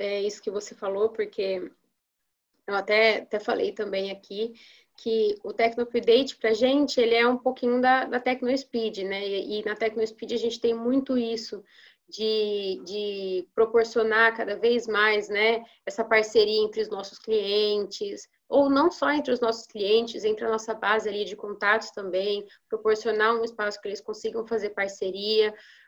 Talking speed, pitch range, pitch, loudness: 170 wpm, 205-235 Hz, 220 Hz, -26 LUFS